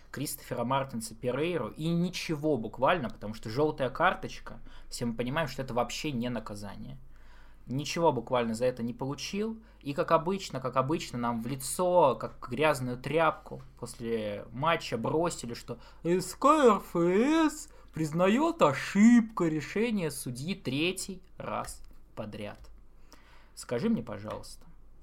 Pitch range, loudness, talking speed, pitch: 120-170 Hz, -30 LUFS, 120 wpm, 140 Hz